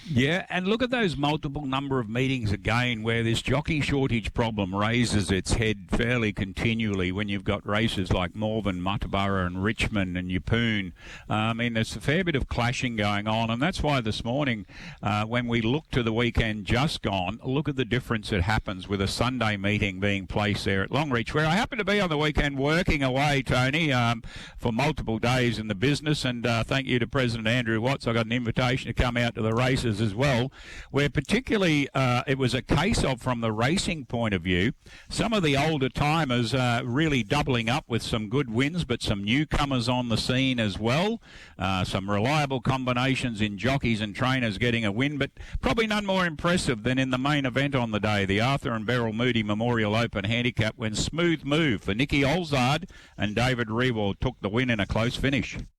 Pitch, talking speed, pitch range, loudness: 120 Hz, 205 wpm, 110-140 Hz, -26 LUFS